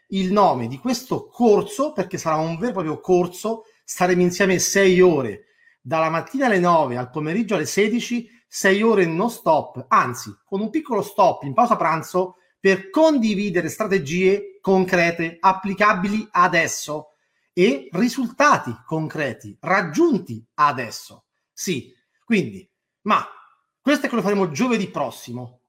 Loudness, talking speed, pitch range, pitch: -20 LUFS, 135 wpm, 160-220 Hz, 190 Hz